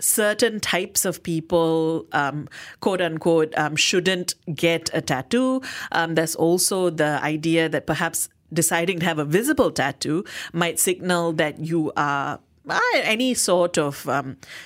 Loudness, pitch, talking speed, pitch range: -22 LUFS, 165 Hz, 145 wpm, 155-185 Hz